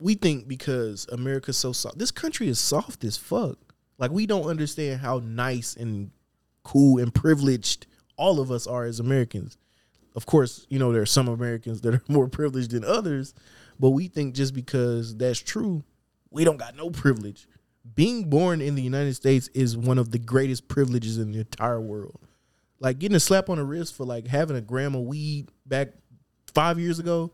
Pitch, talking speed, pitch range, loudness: 130 Hz, 195 wpm, 120-150 Hz, -25 LUFS